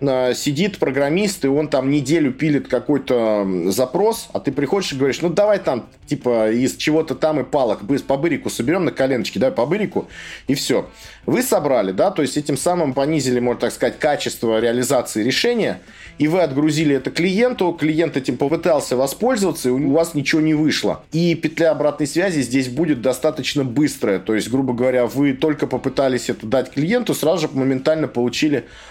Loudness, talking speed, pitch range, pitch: -19 LUFS, 170 wpm, 130-160 Hz, 145 Hz